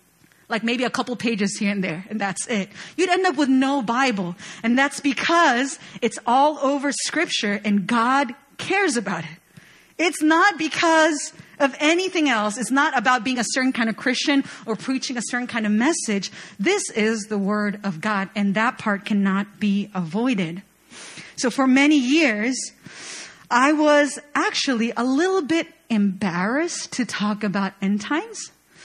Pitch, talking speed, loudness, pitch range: 245 Hz, 165 wpm, -21 LUFS, 205-285 Hz